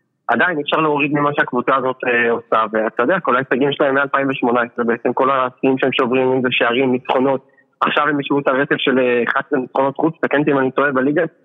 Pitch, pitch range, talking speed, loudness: 135 Hz, 125-145 Hz, 195 wpm, -17 LUFS